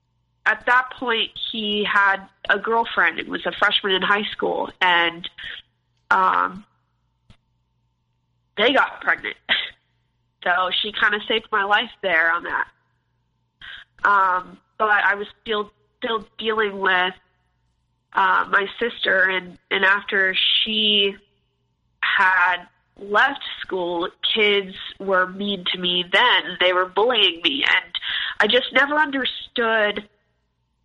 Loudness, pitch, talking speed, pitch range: -20 LUFS, 195 Hz, 120 wpm, 170-215 Hz